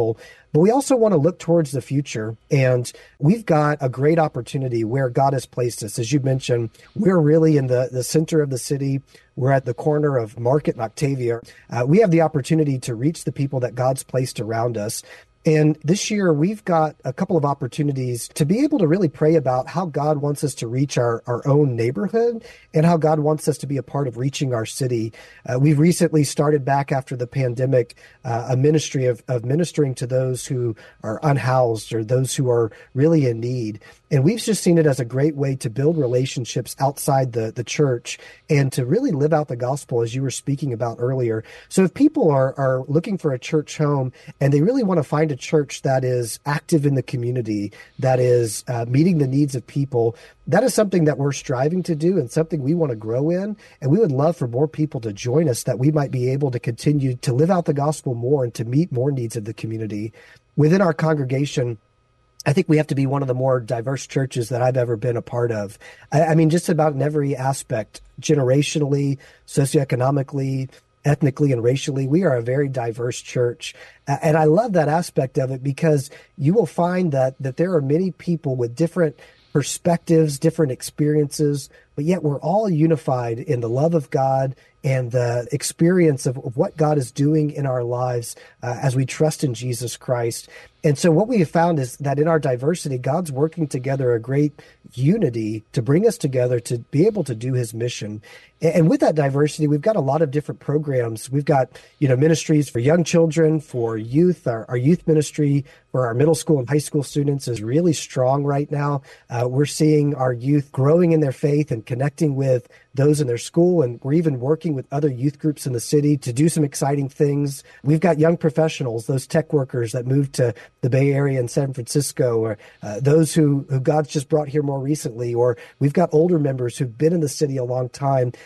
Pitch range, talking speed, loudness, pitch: 125-160 Hz, 210 wpm, -20 LUFS, 145 Hz